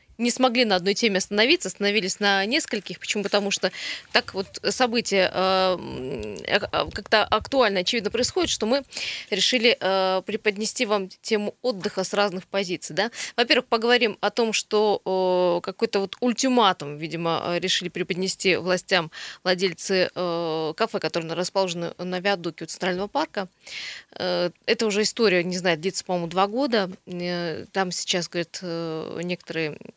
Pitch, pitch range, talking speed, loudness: 190 Hz, 180-220 Hz, 140 wpm, -24 LUFS